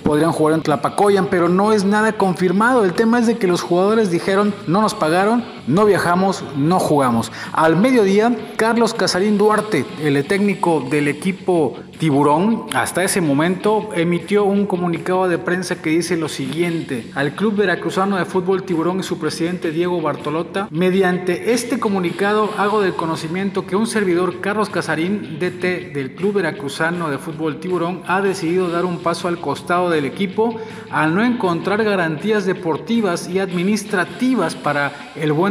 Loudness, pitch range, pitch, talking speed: -18 LUFS, 165-200 Hz, 180 Hz, 160 wpm